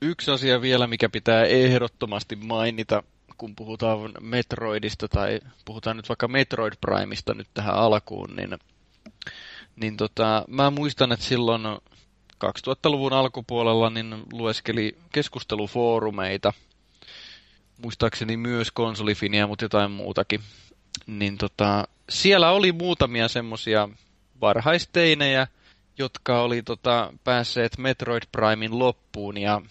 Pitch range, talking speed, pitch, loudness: 105-125 Hz, 105 wpm, 115 Hz, -24 LUFS